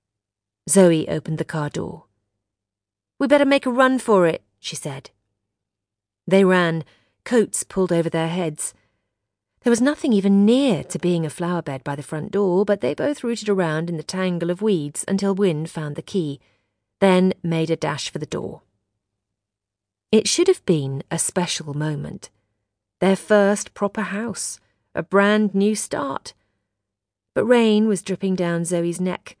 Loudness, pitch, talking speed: -21 LUFS, 165 Hz, 160 wpm